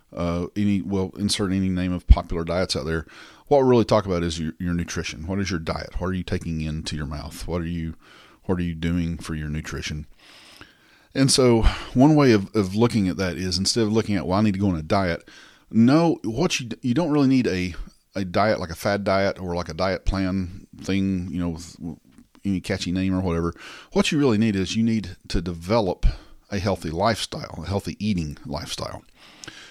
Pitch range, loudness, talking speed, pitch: 85-105 Hz, -23 LUFS, 215 wpm, 95 Hz